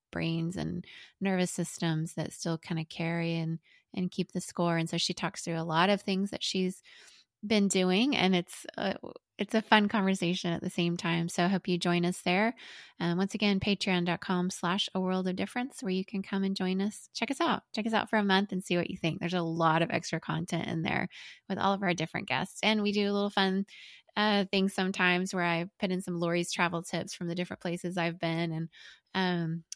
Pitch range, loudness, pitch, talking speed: 170-195 Hz, -31 LUFS, 180 Hz, 230 wpm